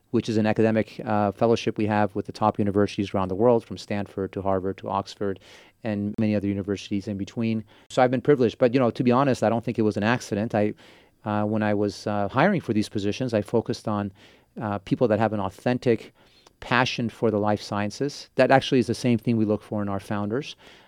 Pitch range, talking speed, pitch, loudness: 100-120 Hz, 230 wpm, 105 Hz, -25 LUFS